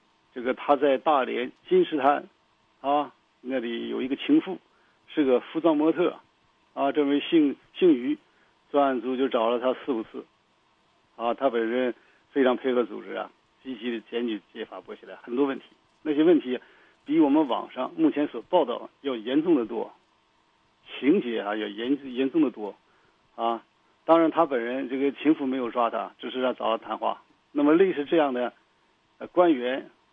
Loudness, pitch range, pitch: -26 LUFS, 125-170 Hz, 140 Hz